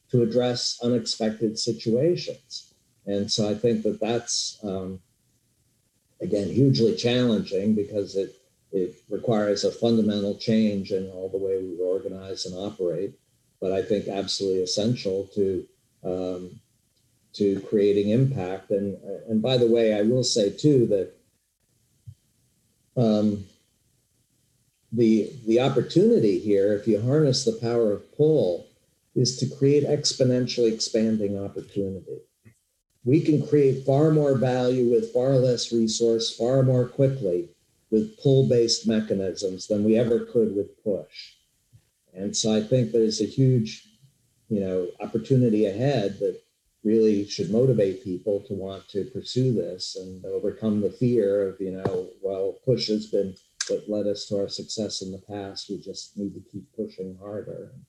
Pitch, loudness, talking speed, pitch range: 110 Hz, -24 LUFS, 145 wpm, 100-125 Hz